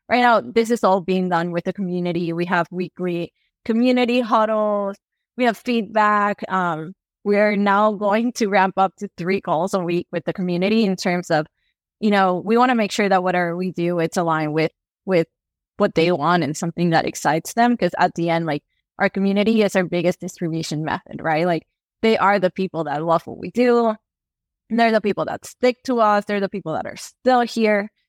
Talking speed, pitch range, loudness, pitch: 205 wpm, 175-215 Hz, -20 LUFS, 190 Hz